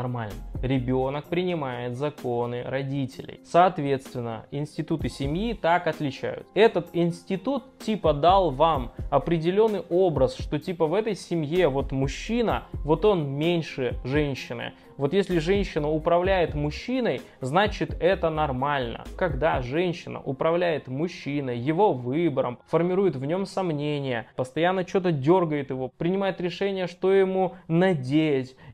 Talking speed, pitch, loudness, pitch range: 115 wpm, 160 Hz, -25 LUFS, 135-180 Hz